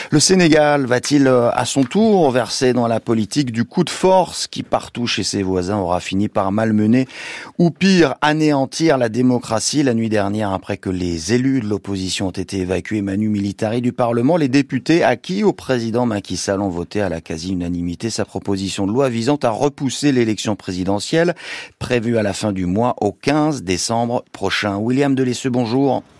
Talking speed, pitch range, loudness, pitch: 175 wpm, 100-135 Hz, -18 LUFS, 115 Hz